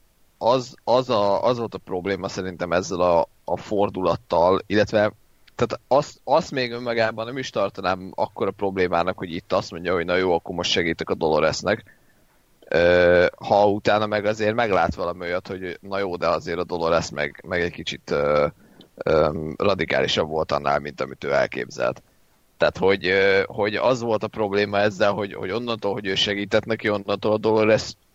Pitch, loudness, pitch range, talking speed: 100 Hz, -22 LUFS, 90-110 Hz, 175 wpm